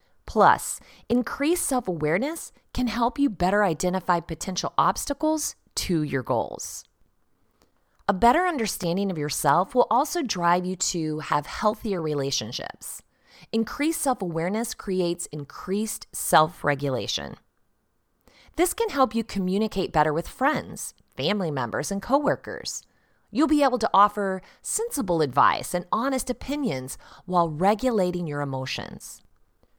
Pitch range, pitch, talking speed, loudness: 165-250 Hz, 195 Hz, 120 wpm, -25 LUFS